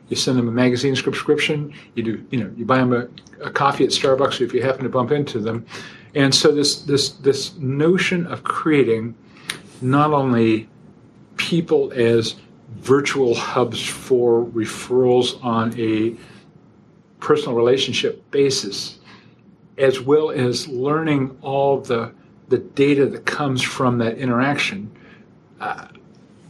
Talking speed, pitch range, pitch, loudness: 135 wpm, 115-140 Hz, 130 Hz, -19 LUFS